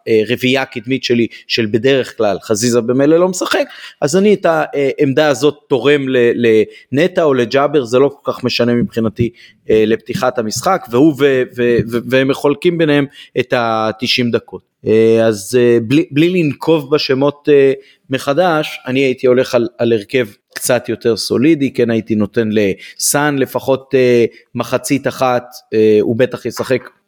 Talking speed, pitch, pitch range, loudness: 135 wpm, 125 Hz, 120-145 Hz, -14 LUFS